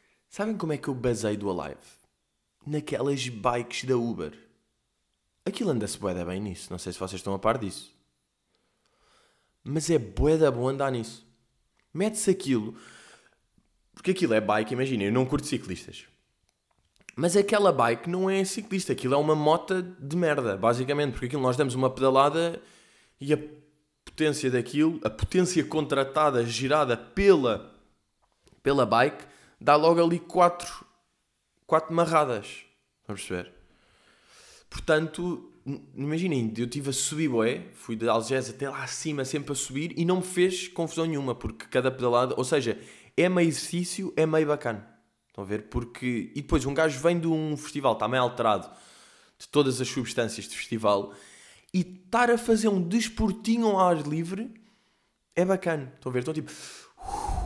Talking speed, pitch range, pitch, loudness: 155 wpm, 120-170 Hz, 145 Hz, -27 LUFS